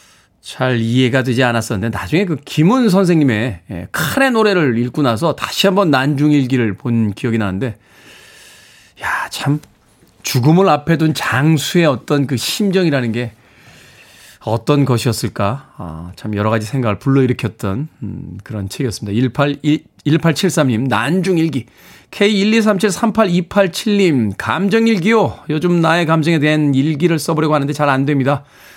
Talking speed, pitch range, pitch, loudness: 275 characters per minute, 120-165 Hz, 140 Hz, -15 LUFS